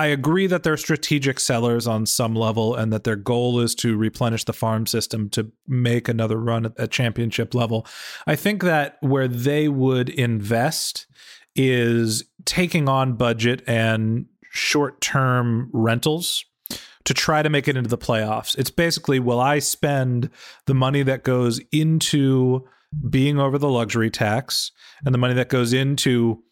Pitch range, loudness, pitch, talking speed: 115-140 Hz, -21 LUFS, 125 Hz, 160 wpm